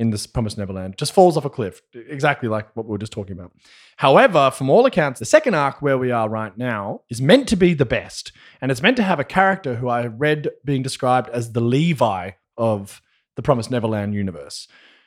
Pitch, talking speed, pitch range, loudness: 125 Hz, 220 wpm, 110-145 Hz, -19 LUFS